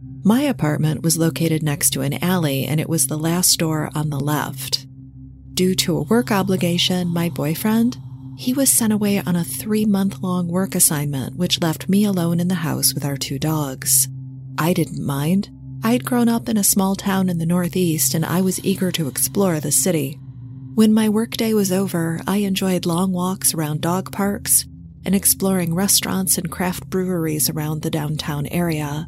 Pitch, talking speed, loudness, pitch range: 170 Hz, 180 wpm, -19 LUFS, 145-190 Hz